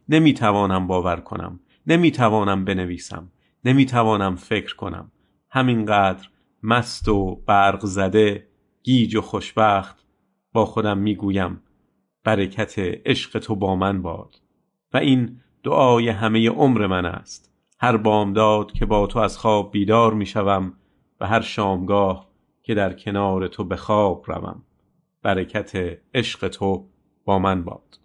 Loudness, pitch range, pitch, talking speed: -20 LUFS, 95-110 Hz, 100 Hz, 120 wpm